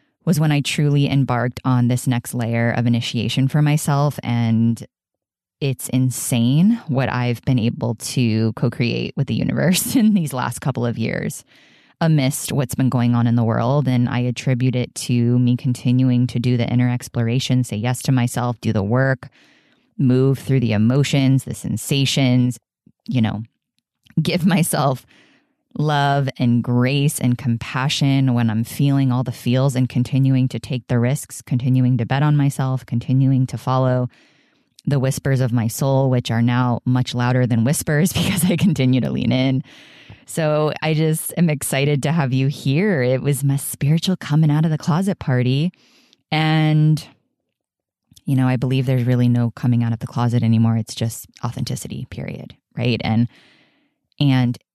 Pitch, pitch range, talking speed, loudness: 130 Hz, 120-145 Hz, 165 wpm, -19 LUFS